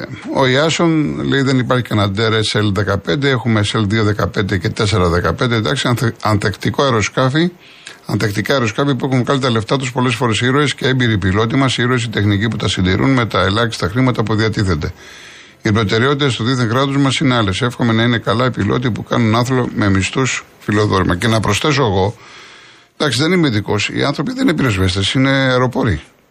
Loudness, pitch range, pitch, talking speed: -15 LUFS, 105-130 Hz, 115 Hz, 175 wpm